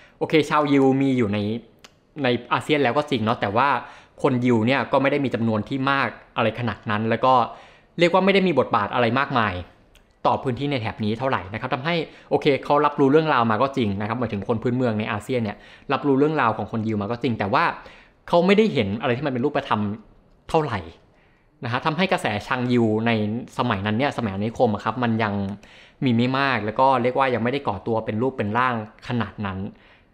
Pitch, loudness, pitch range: 120 Hz, -22 LUFS, 110-135 Hz